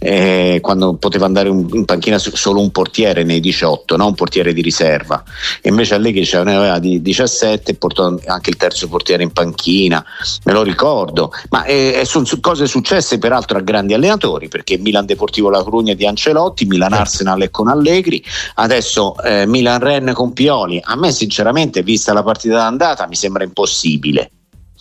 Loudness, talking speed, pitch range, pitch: -13 LUFS, 165 wpm, 95-115 Hz, 100 Hz